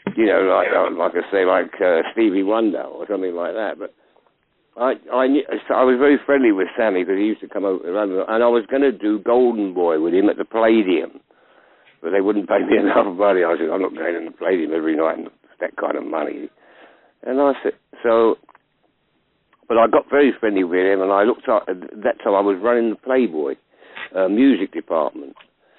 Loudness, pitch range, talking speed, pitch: -19 LUFS, 105-140 Hz, 215 wpm, 120 Hz